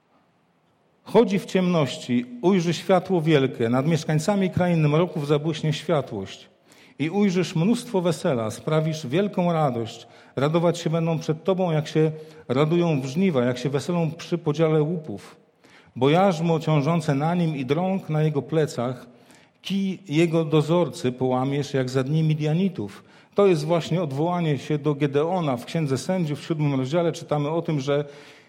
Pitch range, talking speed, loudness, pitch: 145-175 Hz, 145 wpm, -23 LUFS, 155 Hz